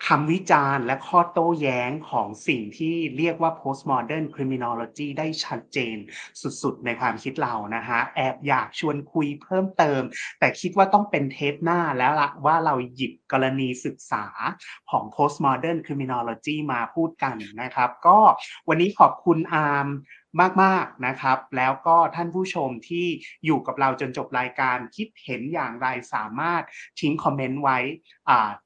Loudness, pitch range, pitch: -23 LUFS, 130-165 Hz, 145 Hz